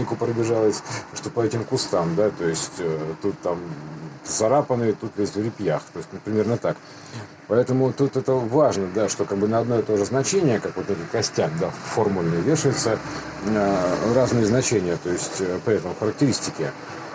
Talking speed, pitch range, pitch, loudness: 180 wpm, 100-130 Hz, 110 Hz, -23 LUFS